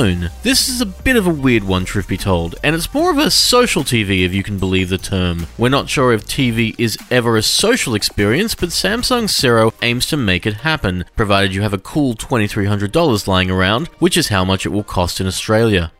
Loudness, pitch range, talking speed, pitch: -15 LUFS, 95-150 Hz, 220 wpm, 110 Hz